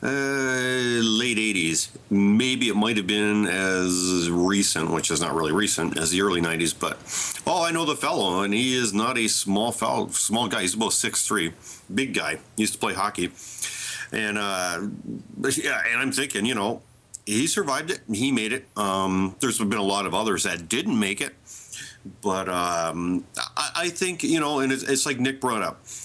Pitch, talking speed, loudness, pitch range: 105 Hz, 195 wpm, -24 LUFS, 90-130 Hz